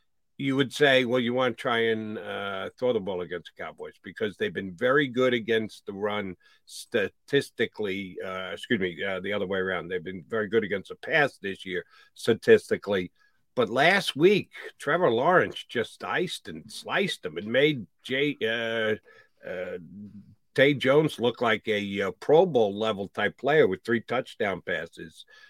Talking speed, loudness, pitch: 170 wpm, -26 LUFS, 125 Hz